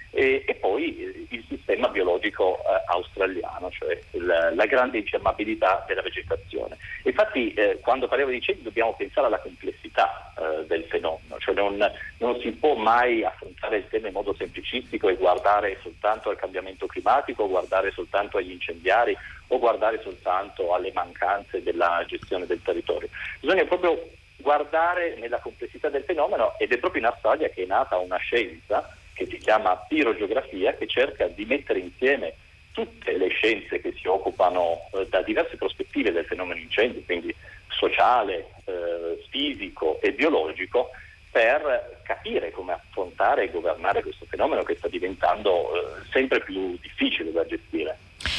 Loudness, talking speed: -25 LUFS, 150 wpm